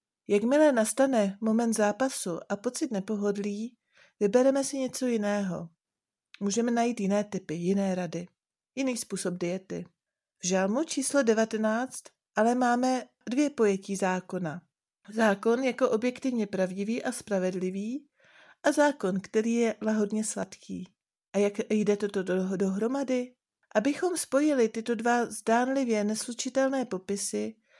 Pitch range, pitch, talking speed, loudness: 195-250 Hz, 220 Hz, 115 wpm, -28 LUFS